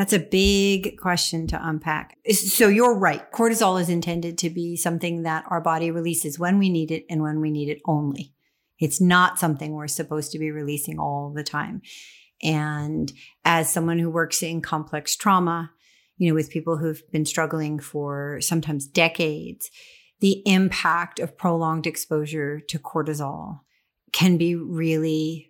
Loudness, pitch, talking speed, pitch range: -23 LUFS, 165 Hz, 160 wpm, 155-175 Hz